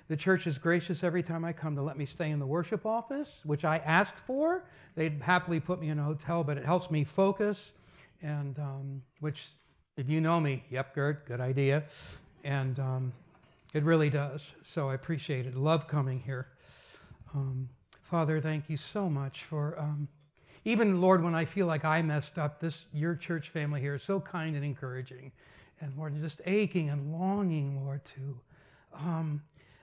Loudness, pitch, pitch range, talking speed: -32 LUFS, 150 Hz, 140-170 Hz, 185 wpm